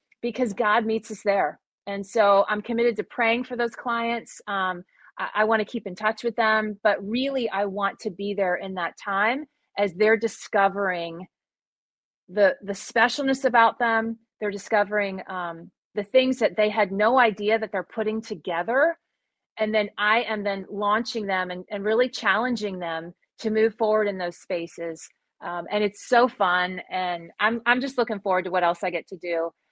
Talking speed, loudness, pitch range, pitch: 185 wpm, -24 LUFS, 190-230 Hz, 210 Hz